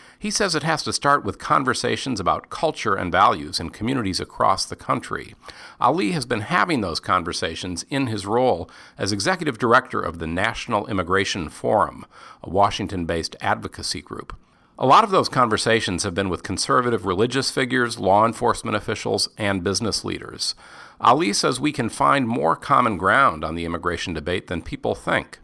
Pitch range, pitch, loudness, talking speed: 90-120 Hz, 100 Hz, -21 LUFS, 165 wpm